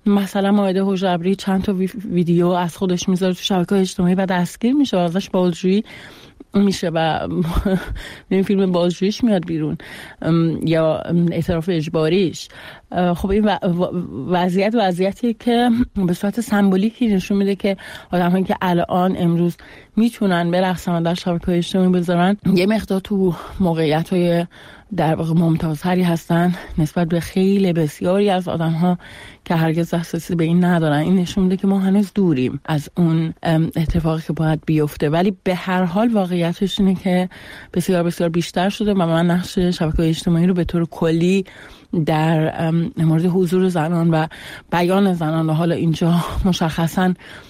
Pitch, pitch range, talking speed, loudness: 180 Hz, 170-195 Hz, 150 wpm, -18 LUFS